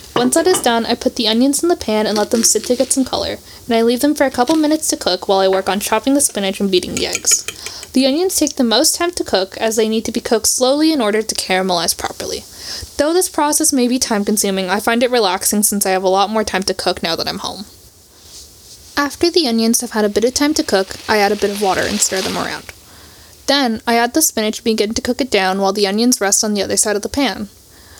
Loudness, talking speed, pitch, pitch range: -15 LUFS, 270 wpm, 230 Hz, 200-275 Hz